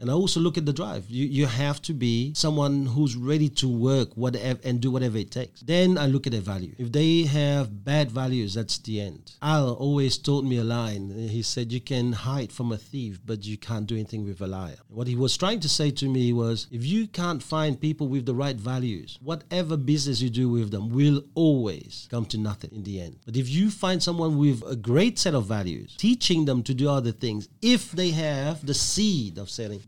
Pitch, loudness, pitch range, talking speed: 130 Hz, -26 LUFS, 115-150 Hz, 230 wpm